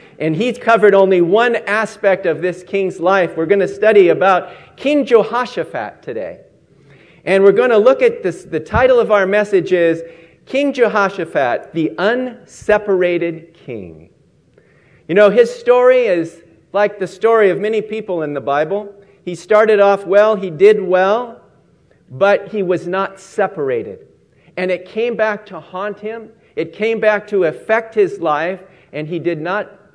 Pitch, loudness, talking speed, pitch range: 200 Hz, -15 LUFS, 160 wpm, 175-220 Hz